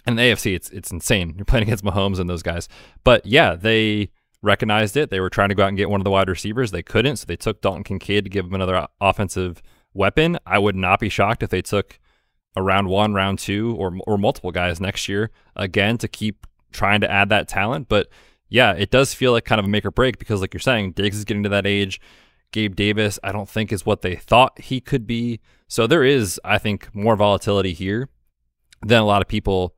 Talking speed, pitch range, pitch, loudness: 240 wpm, 95-110 Hz, 100 Hz, -20 LUFS